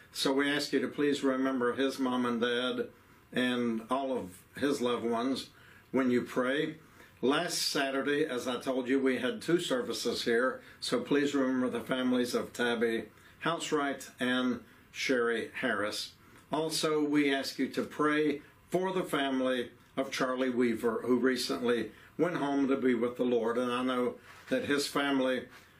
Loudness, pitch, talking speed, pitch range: -31 LUFS, 130 Hz, 160 wpm, 120-140 Hz